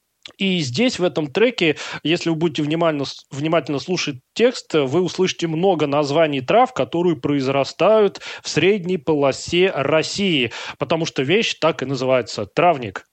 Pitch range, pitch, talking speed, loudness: 145-185 Hz, 165 Hz, 135 wpm, -19 LUFS